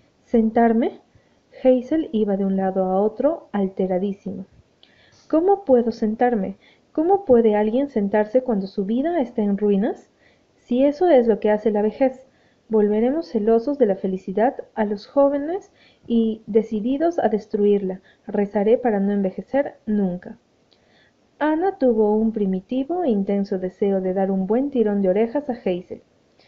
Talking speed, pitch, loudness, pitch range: 145 wpm, 220 Hz, -21 LUFS, 200-255 Hz